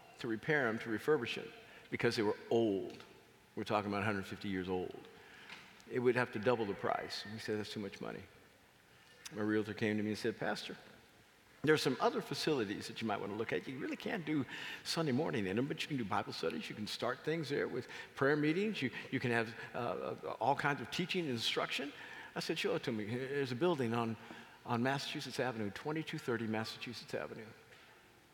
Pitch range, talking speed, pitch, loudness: 110-145 Hz, 210 wpm, 120 Hz, -38 LUFS